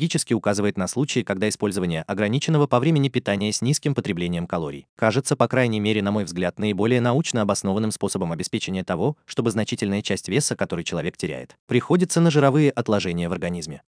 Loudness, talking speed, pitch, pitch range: -23 LUFS, 165 wpm, 110 Hz, 100-140 Hz